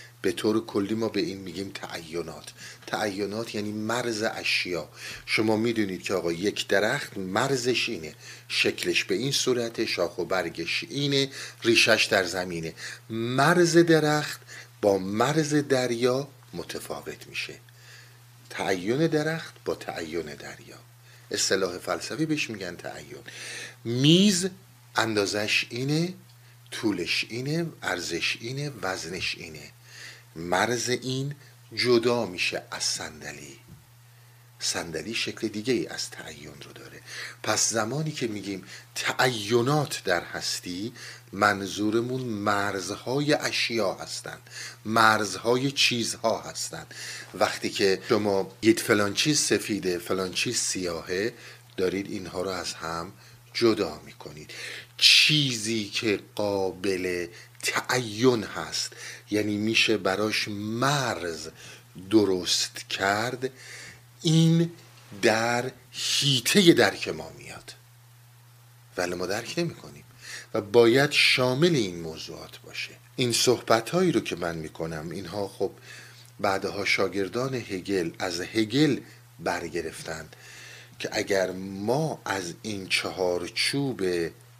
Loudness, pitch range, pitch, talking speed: -26 LUFS, 100-125 Hz, 120 Hz, 105 wpm